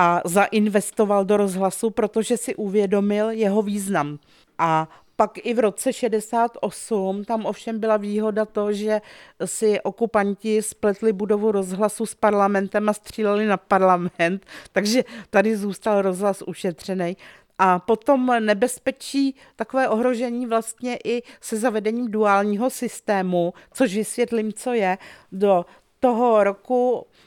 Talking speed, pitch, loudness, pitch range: 120 wpm, 215 Hz, -22 LUFS, 200-230 Hz